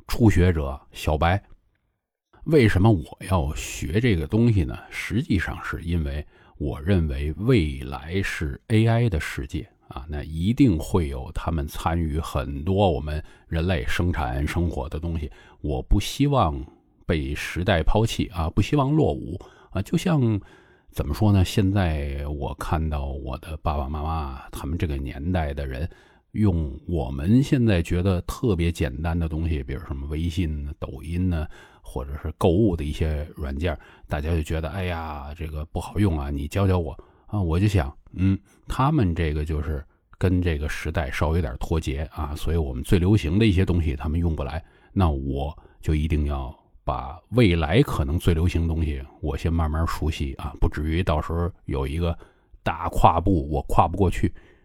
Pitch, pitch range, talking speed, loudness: 85 Hz, 75-95 Hz, 255 characters per minute, -25 LUFS